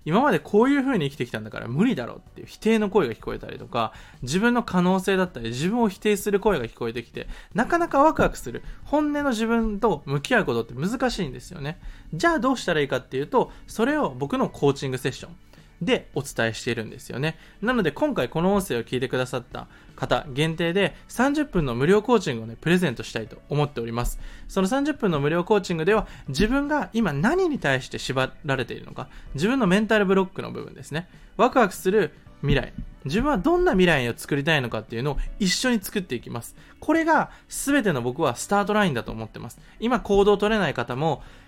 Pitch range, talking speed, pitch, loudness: 135-220 Hz, 445 characters per minute, 180 Hz, -24 LUFS